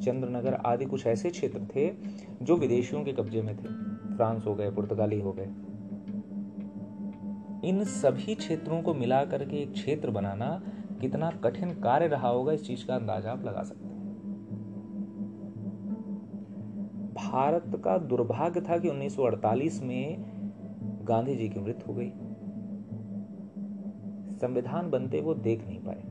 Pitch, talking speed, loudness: 125 Hz, 135 wpm, -32 LUFS